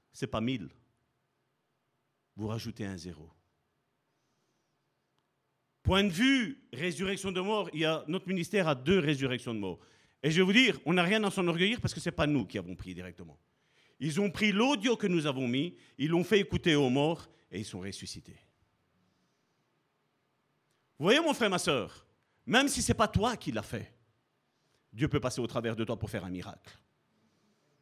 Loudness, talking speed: -30 LUFS, 190 wpm